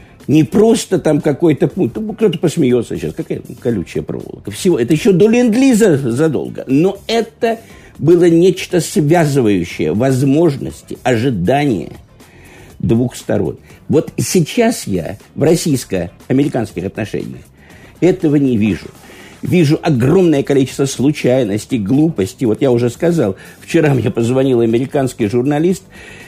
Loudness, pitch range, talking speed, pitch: -14 LUFS, 120-175 Hz, 110 wpm, 145 Hz